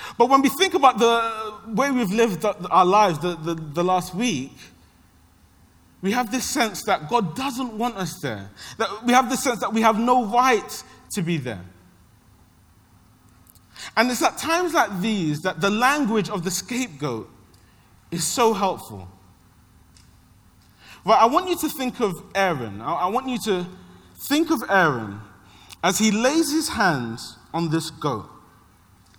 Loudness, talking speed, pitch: -22 LUFS, 160 wpm, 185 Hz